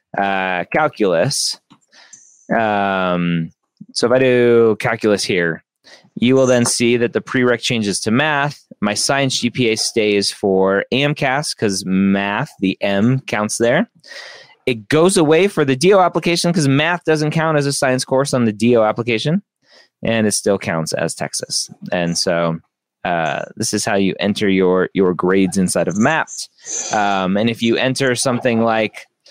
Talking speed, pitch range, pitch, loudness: 160 wpm, 100-135 Hz, 115 Hz, -16 LUFS